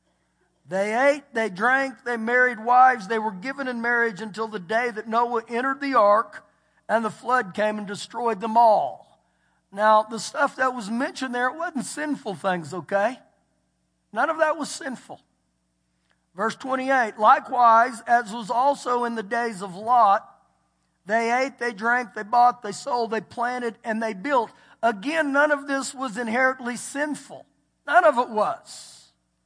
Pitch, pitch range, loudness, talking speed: 235 Hz, 215-260 Hz, -23 LUFS, 165 wpm